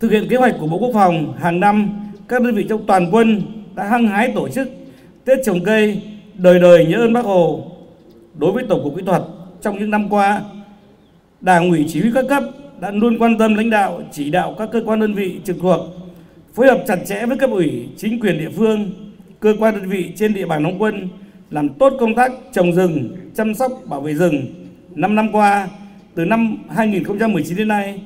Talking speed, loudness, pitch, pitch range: 215 wpm, -16 LUFS, 200 Hz, 180-220 Hz